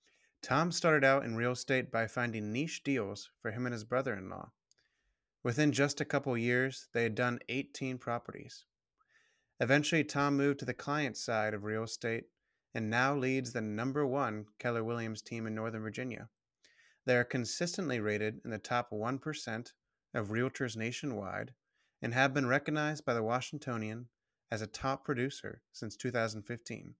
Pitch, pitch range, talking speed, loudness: 125 Hz, 115-140 Hz, 160 wpm, -35 LUFS